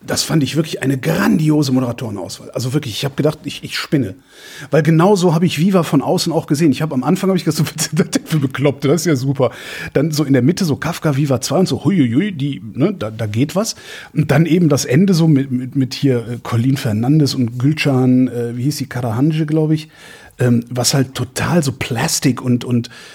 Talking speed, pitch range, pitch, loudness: 220 wpm, 130-160 Hz, 145 Hz, -16 LUFS